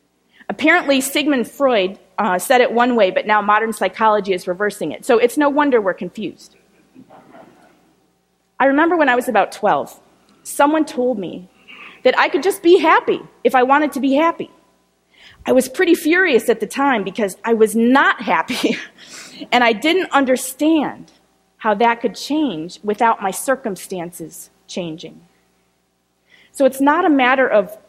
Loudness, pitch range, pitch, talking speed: -16 LUFS, 210-295 Hz, 250 Hz, 155 wpm